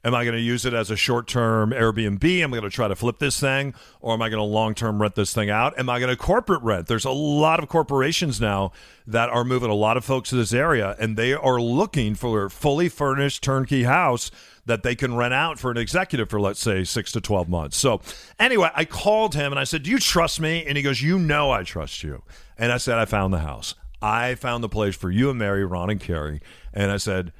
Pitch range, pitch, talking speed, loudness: 105-135 Hz, 120 Hz, 260 wpm, -22 LUFS